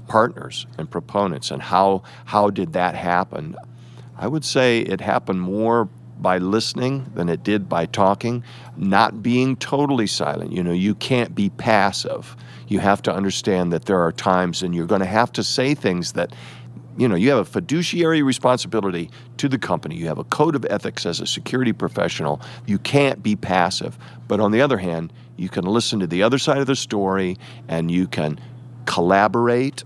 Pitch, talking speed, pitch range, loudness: 105 Hz, 185 wpm, 90-125 Hz, -20 LUFS